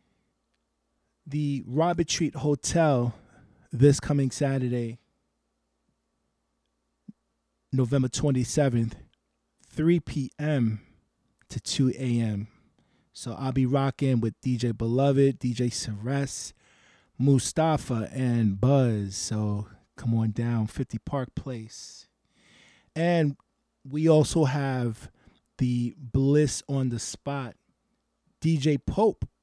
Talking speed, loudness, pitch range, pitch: 90 wpm, -26 LUFS, 110-140 Hz, 130 Hz